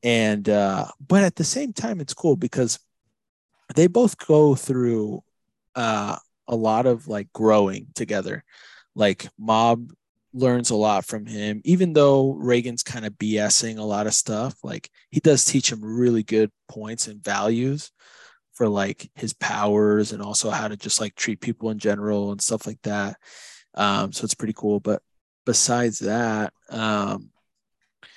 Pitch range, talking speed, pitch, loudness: 105-135 Hz, 160 wpm, 115 Hz, -22 LUFS